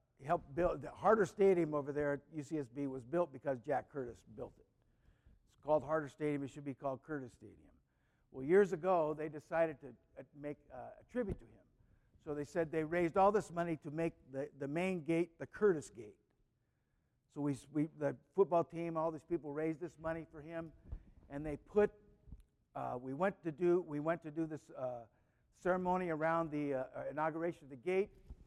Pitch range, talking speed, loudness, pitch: 135-170 Hz, 195 wpm, -38 LUFS, 155 Hz